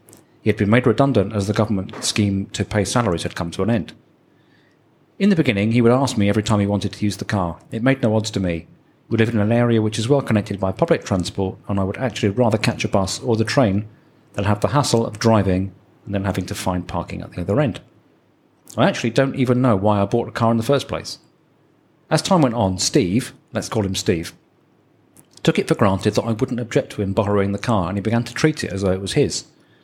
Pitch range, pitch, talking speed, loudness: 100-125 Hz, 110 Hz, 250 wpm, -20 LUFS